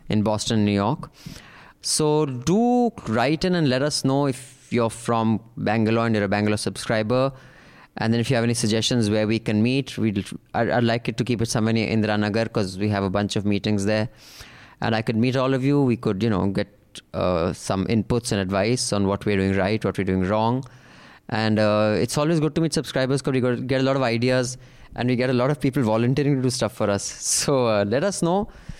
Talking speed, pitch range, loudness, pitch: 230 wpm, 105-130 Hz, -22 LUFS, 115 Hz